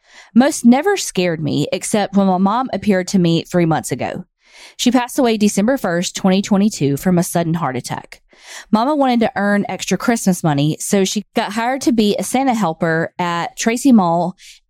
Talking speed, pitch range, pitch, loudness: 180 wpm, 175-230 Hz, 195 Hz, -16 LUFS